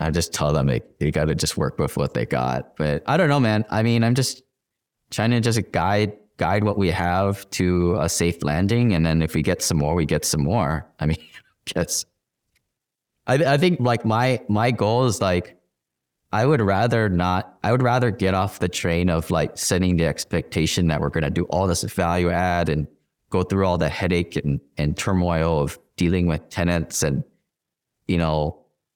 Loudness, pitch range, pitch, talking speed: -22 LUFS, 85-110 Hz, 90 Hz, 205 wpm